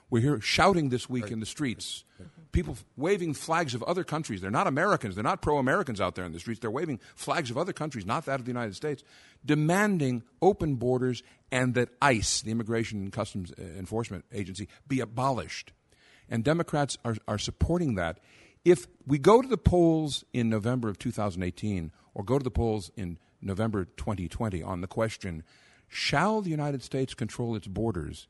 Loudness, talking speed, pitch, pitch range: -29 LUFS, 180 wpm, 120 Hz, 105-145 Hz